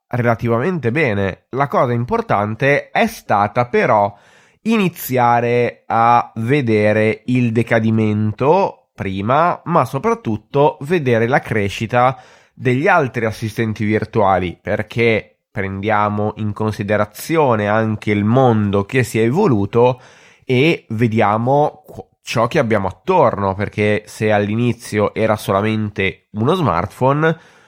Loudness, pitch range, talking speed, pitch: -17 LUFS, 105-125 Hz, 100 wpm, 115 Hz